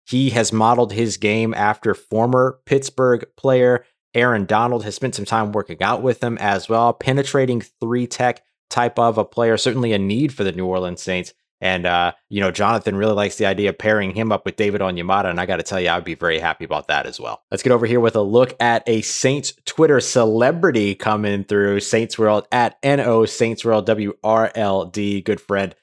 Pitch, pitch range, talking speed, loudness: 110 Hz, 100-120 Hz, 215 wpm, -19 LUFS